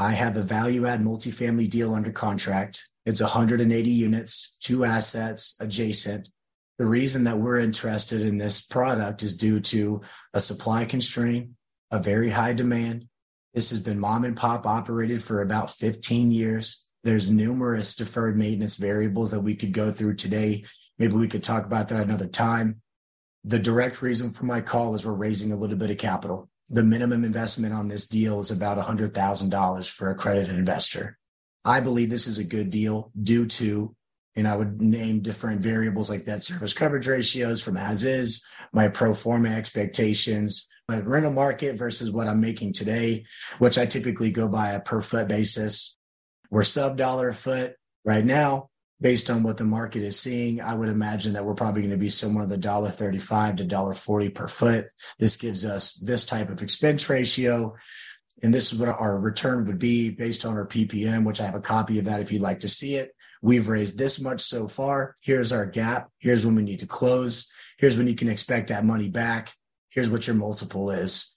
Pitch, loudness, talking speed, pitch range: 110 Hz, -24 LUFS, 190 wpm, 105-120 Hz